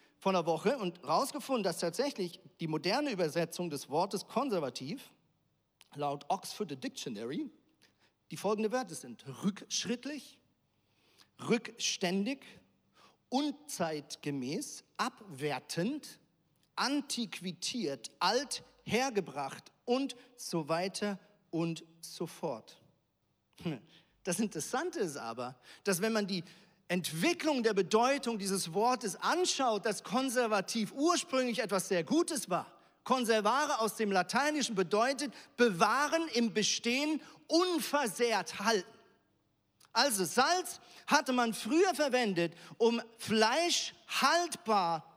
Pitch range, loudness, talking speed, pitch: 180-260 Hz, -33 LUFS, 95 wpm, 220 Hz